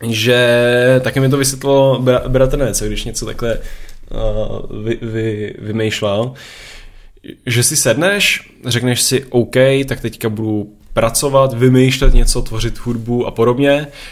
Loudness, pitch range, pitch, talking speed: -15 LUFS, 115-130 Hz, 120 Hz, 130 wpm